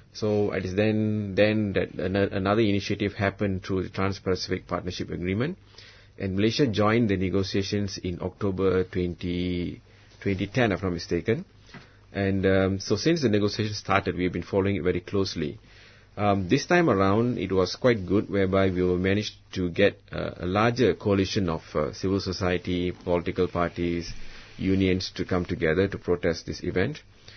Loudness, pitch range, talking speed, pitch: -26 LUFS, 90-105 Hz, 160 wpm, 95 Hz